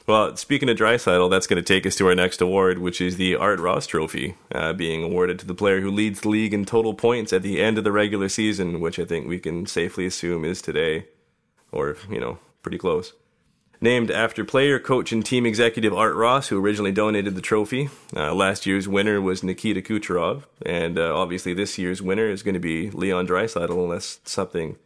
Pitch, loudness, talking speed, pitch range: 100 Hz, -22 LUFS, 210 wpm, 90-110 Hz